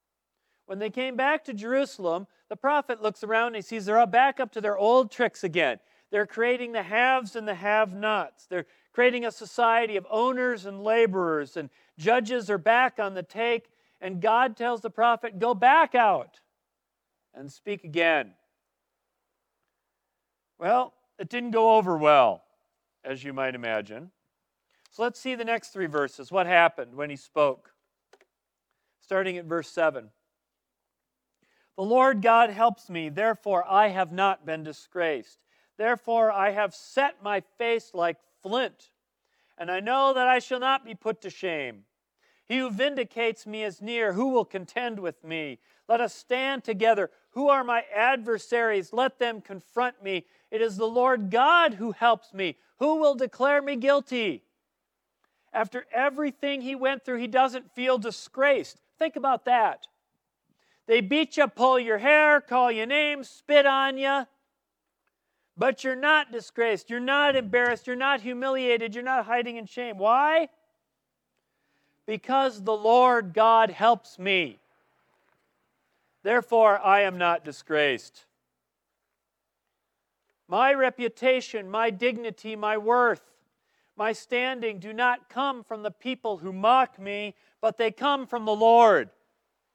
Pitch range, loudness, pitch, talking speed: 200-255 Hz, -25 LUFS, 230 Hz, 150 wpm